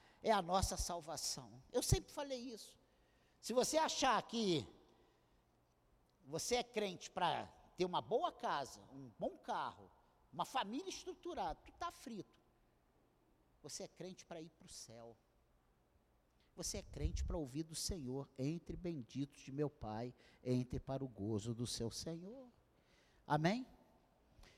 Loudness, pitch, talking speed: -42 LUFS, 160 Hz, 140 wpm